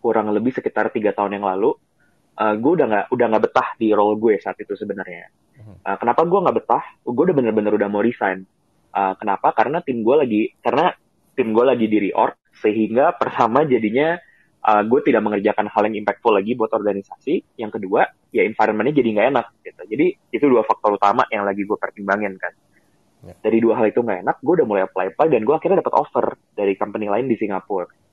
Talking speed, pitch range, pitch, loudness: 200 wpm, 100-115 Hz, 105 Hz, -19 LUFS